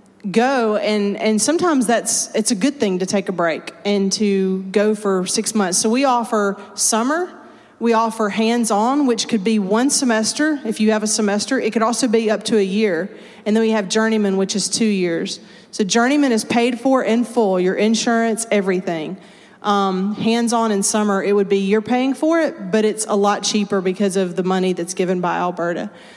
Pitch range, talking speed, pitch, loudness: 200-230 Hz, 200 wpm, 215 Hz, -18 LUFS